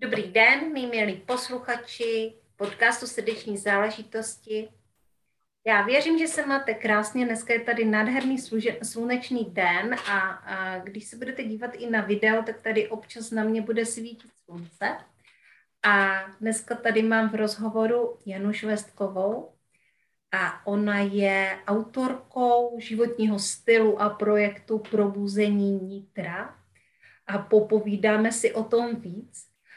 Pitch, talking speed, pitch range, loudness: 220 Hz, 125 wpm, 205-235 Hz, -25 LUFS